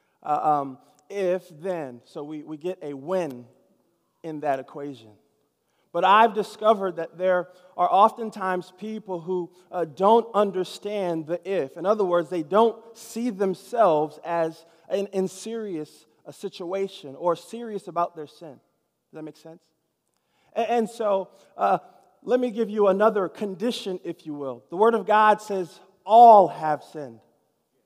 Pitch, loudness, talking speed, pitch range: 185 Hz, -24 LUFS, 150 wpm, 160-205 Hz